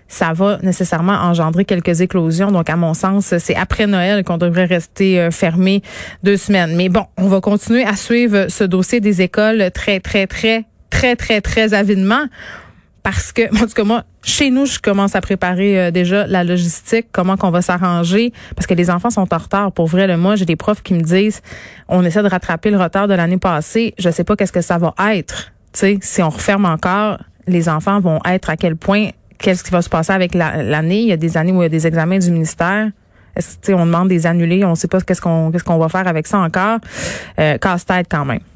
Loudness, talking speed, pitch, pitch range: -15 LUFS, 230 wpm, 185 Hz, 175-205 Hz